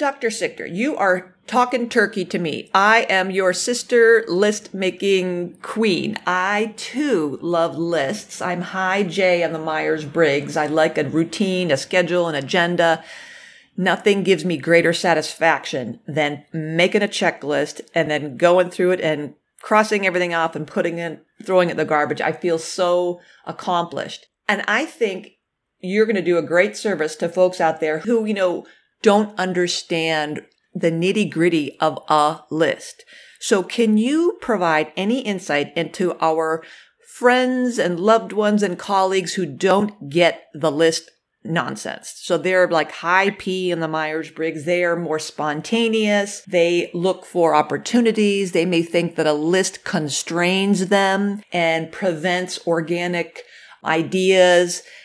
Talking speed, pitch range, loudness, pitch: 150 wpm, 165-200 Hz, -19 LUFS, 180 Hz